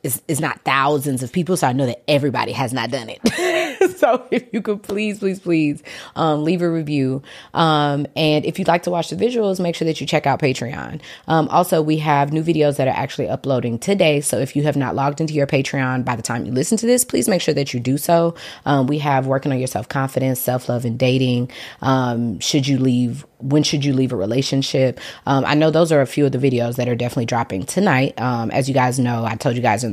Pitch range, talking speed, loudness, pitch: 130-160 Hz, 245 wpm, -19 LUFS, 140 Hz